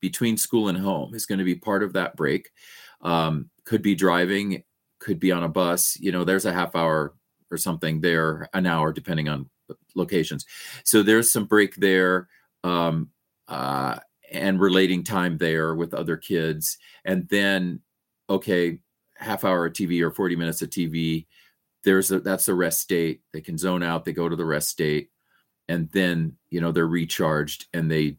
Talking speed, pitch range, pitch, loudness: 185 wpm, 80-95 Hz, 90 Hz, -24 LUFS